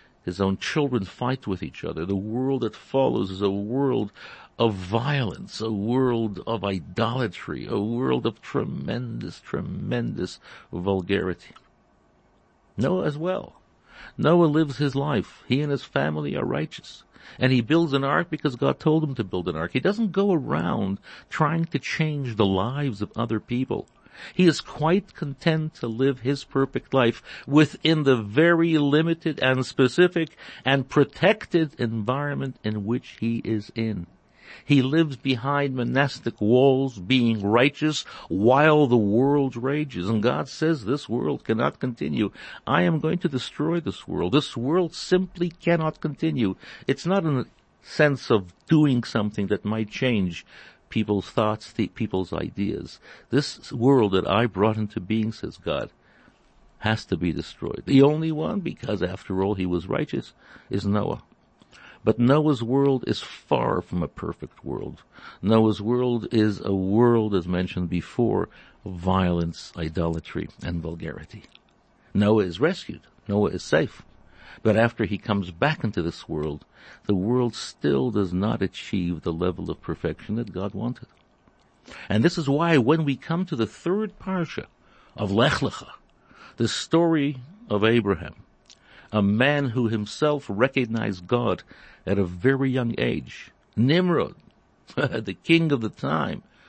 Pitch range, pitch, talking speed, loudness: 100-145 Hz, 120 Hz, 150 wpm, -24 LUFS